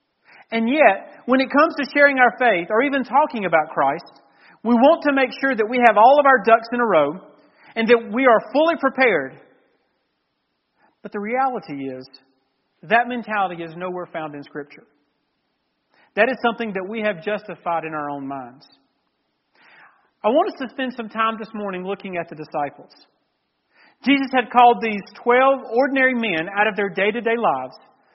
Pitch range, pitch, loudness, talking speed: 170-255 Hz, 225 Hz, -19 LUFS, 180 wpm